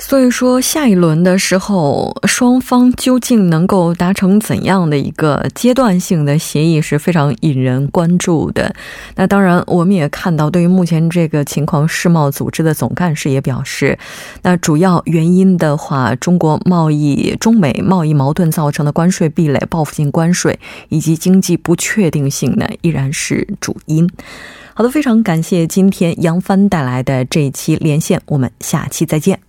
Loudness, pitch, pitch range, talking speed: -13 LUFS, 170 Hz, 150-190 Hz, 265 characters per minute